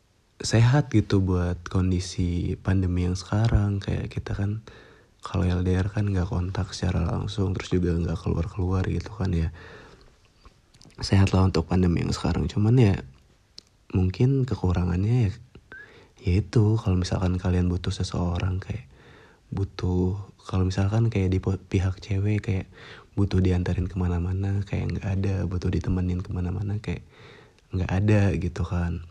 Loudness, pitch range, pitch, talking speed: -26 LUFS, 90-105 Hz, 95 Hz, 135 wpm